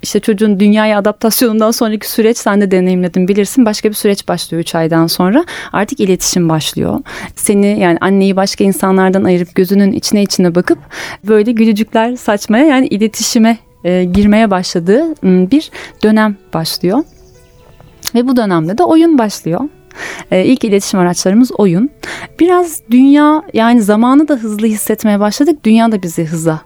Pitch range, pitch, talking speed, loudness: 185-230 Hz, 210 Hz, 145 wpm, -11 LUFS